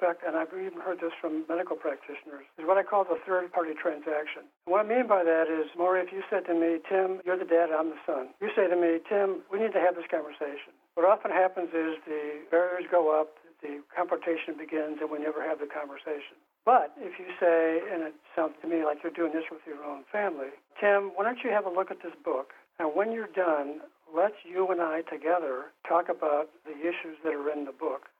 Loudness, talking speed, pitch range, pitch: -29 LUFS, 230 wpm, 155-185 Hz, 165 Hz